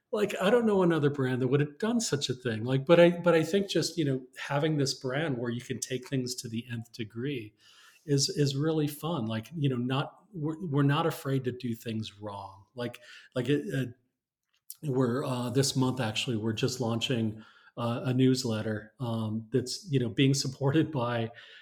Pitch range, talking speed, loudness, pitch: 120-145 Hz, 195 wpm, -30 LUFS, 130 Hz